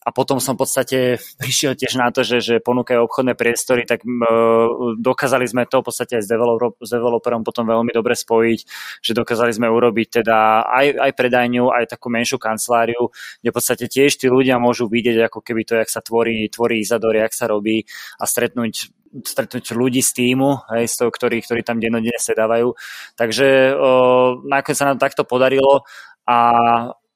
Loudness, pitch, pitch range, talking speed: -17 LUFS, 120 Hz, 115-130 Hz, 180 wpm